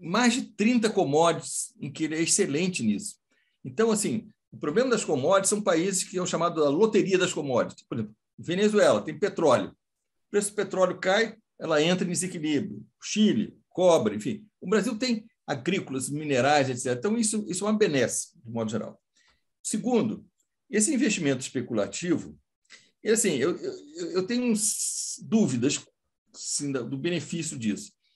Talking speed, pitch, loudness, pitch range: 155 wpm, 190 Hz, -26 LUFS, 155-220 Hz